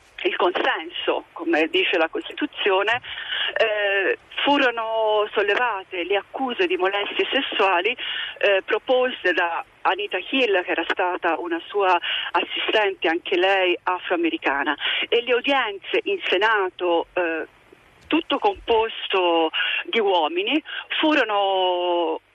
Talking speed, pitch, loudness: 105 wpm, 205 Hz, -22 LUFS